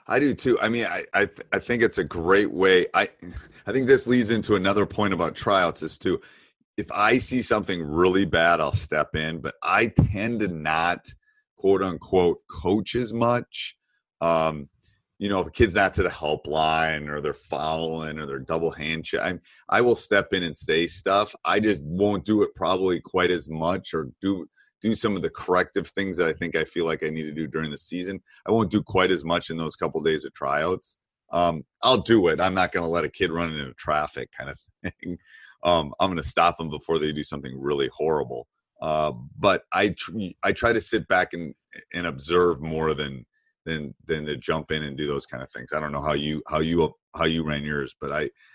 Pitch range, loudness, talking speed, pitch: 75-105 Hz, -24 LUFS, 220 wpm, 85 Hz